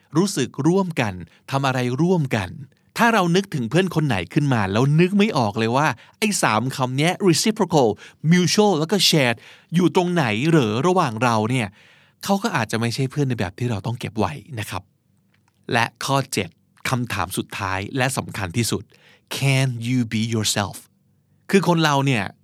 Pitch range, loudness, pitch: 115-170 Hz, -21 LUFS, 135 Hz